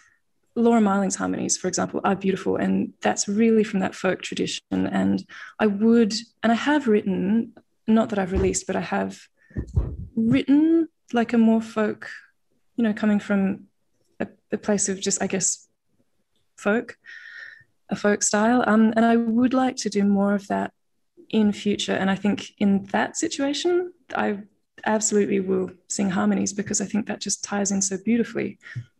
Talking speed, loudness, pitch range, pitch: 165 wpm, -23 LUFS, 195-230 Hz, 210 Hz